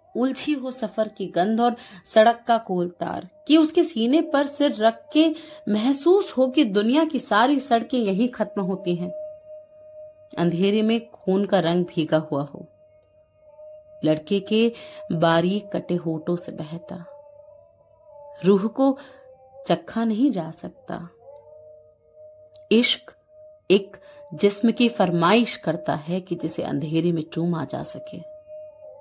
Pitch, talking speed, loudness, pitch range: 230 Hz, 130 wpm, -22 LUFS, 185-300 Hz